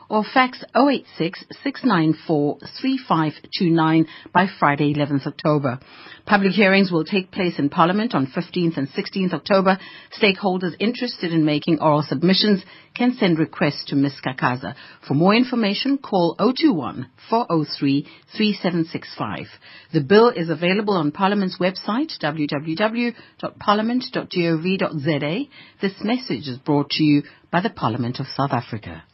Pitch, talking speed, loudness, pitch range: 175 Hz, 125 wpm, -20 LUFS, 150-205 Hz